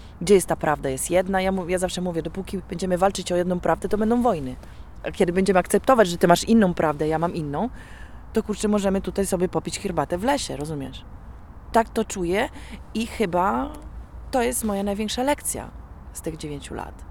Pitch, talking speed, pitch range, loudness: 190 Hz, 200 wpm, 175-215 Hz, -23 LUFS